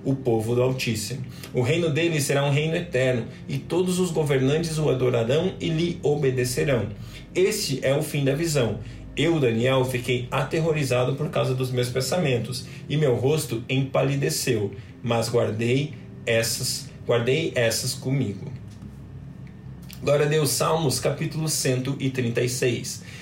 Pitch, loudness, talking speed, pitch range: 130 Hz, -24 LUFS, 130 wpm, 125-150 Hz